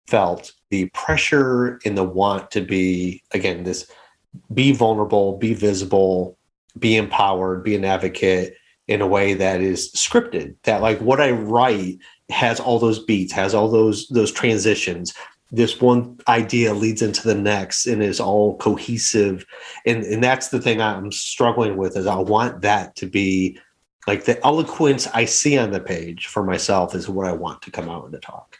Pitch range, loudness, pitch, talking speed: 95-115 Hz, -19 LUFS, 105 Hz, 175 wpm